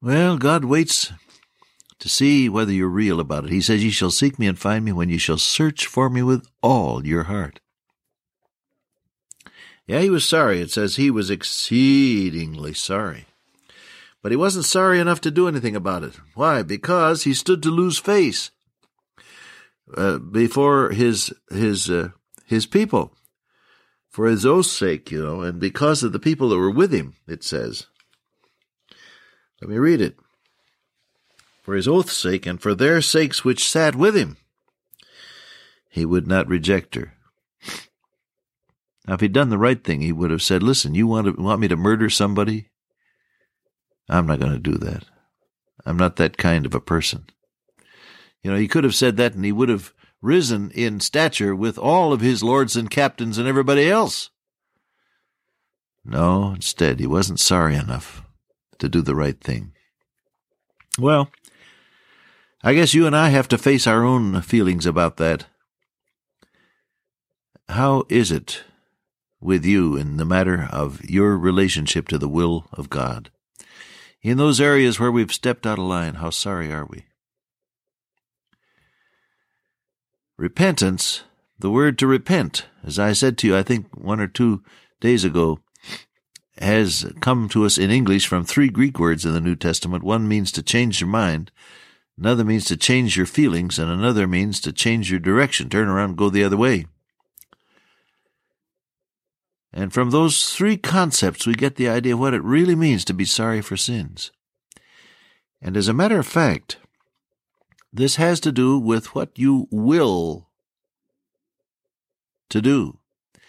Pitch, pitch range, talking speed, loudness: 110 Hz, 90-135 Hz, 160 wpm, -19 LUFS